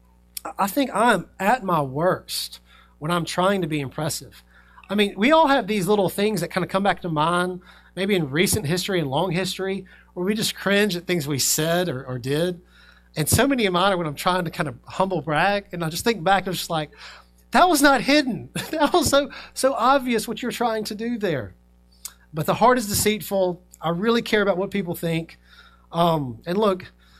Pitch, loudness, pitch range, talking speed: 180 Hz, -22 LUFS, 155-210 Hz, 215 wpm